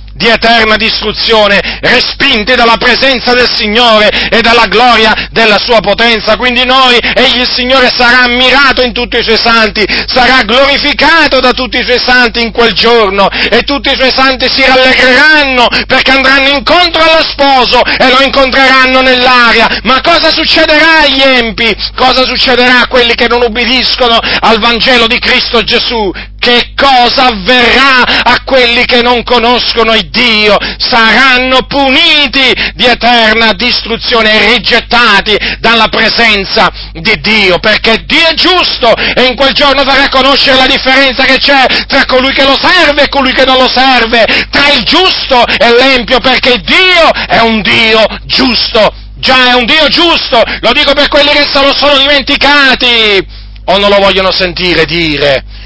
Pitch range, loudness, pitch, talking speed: 225-270 Hz, -5 LUFS, 250 Hz, 155 wpm